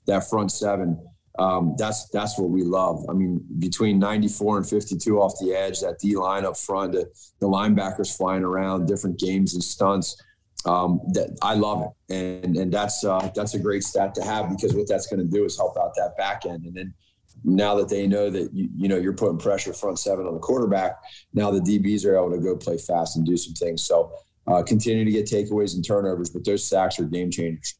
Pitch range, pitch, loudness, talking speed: 90-105 Hz, 95 Hz, -24 LUFS, 230 wpm